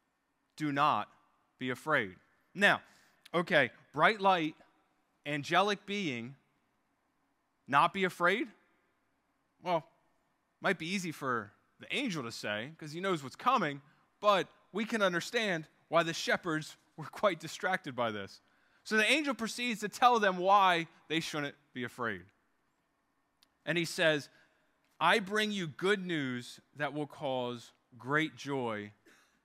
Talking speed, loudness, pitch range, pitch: 130 wpm, -32 LUFS, 140-190 Hz, 160 Hz